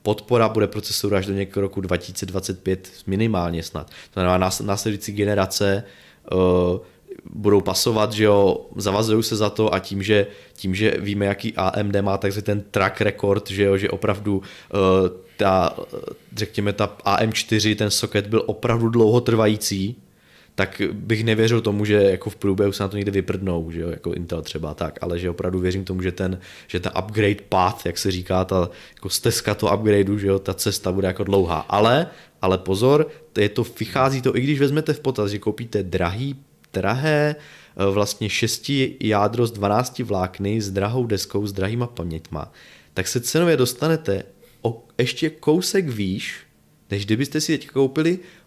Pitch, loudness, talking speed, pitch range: 100 Hz, -21 LUFS, 170 wpm, 95-110 Hz